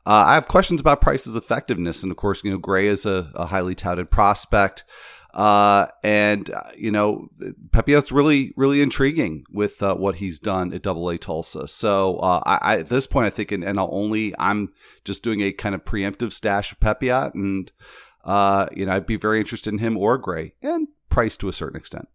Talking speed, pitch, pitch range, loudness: 205 wpm, 100 Hz, 95-115 Hz, -21 LUFS